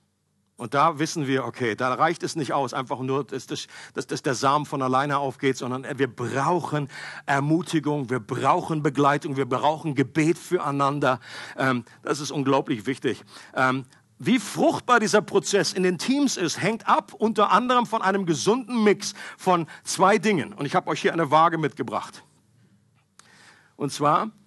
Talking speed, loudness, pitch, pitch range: 150 wpm, -24 LUFS, 150 Hz, 135-180 Hz